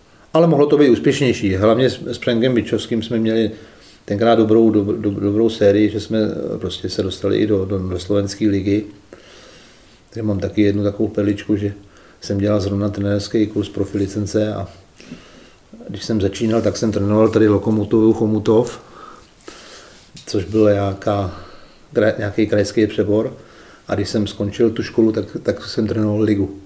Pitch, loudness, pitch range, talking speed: 105 Hz, -18 LUFS, 100-110 Hz, 150 wpm